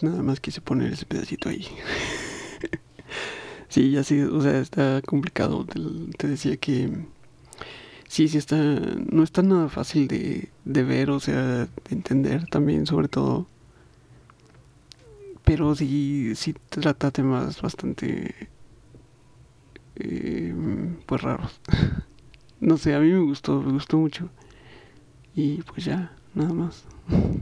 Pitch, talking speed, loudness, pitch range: 145 Hz, 125 wpm, -25 LUFS, 135-160 Hz